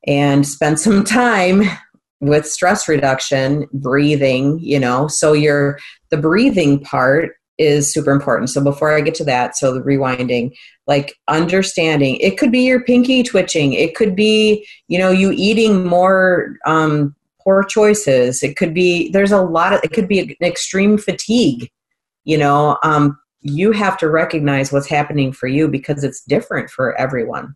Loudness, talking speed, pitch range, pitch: -15 LUFS, 165 wpm, 140-190 Hz, 155 Hz